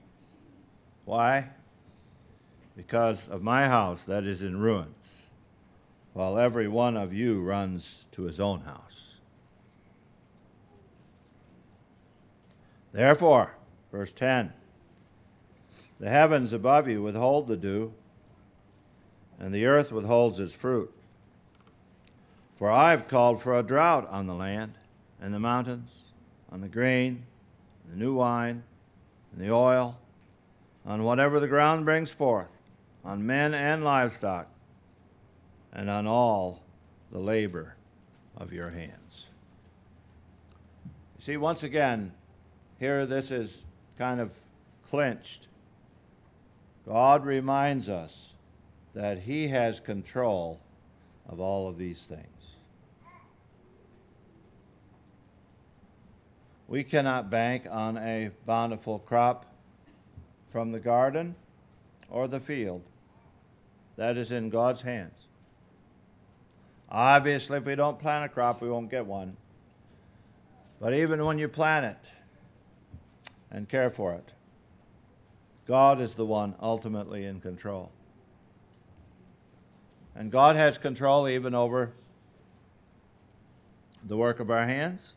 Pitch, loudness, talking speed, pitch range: 110 Hz, -27 LUFS, 110 wpm, 95-125 Hz